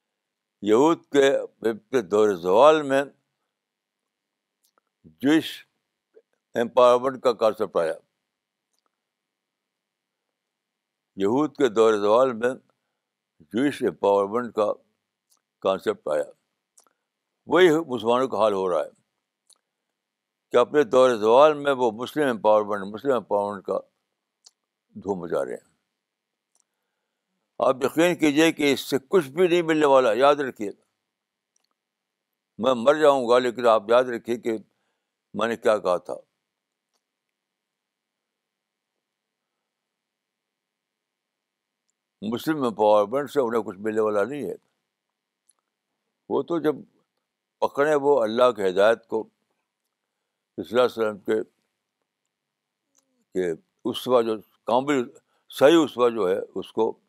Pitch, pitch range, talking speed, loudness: 125 Hz, 110-150 Hz, 105 wpm, -22 LUFS